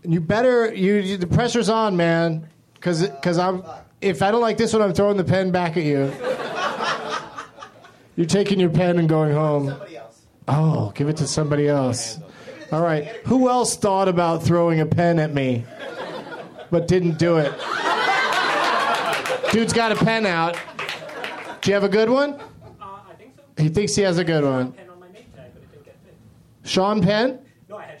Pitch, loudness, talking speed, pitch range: 175 Hz, -20 LUFS, 165 wpm, 155-200 Hz